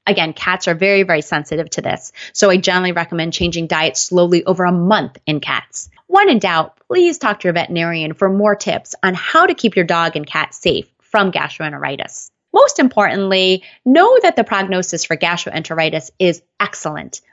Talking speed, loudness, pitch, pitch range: 180 wpm, -15 LUFS, 180 Hz, 165-205 Hz